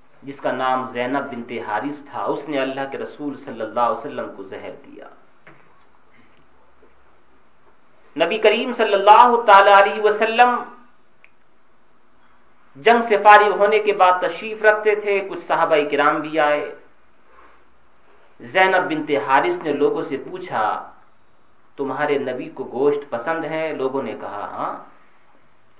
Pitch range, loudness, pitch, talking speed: 140-205 Hz, -18 LUFS, 155 Hz, 130 wpm